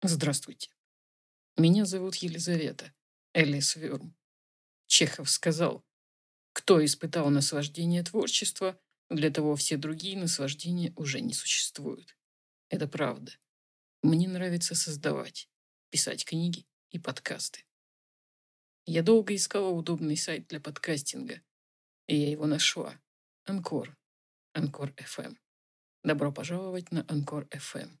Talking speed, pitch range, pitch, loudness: 105 wpm, 145-175 Hz, 155 Hz, -29 LUFS